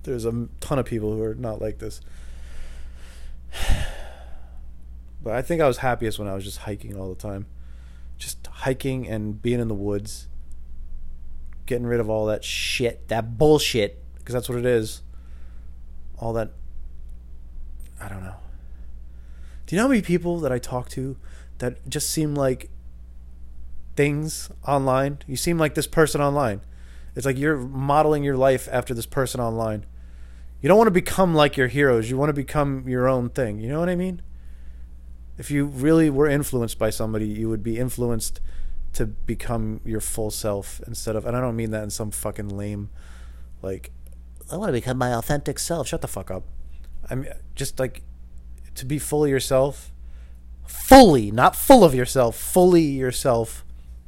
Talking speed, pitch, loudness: 175 wpm, 110 Hz, -22 LUFS